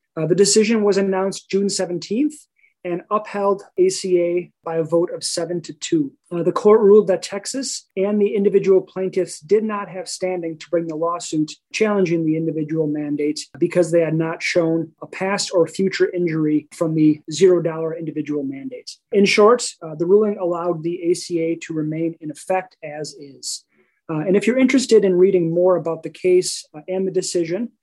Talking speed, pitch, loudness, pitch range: 180 wpm, 180 Hz, -19 LUFS, 165-200 Hz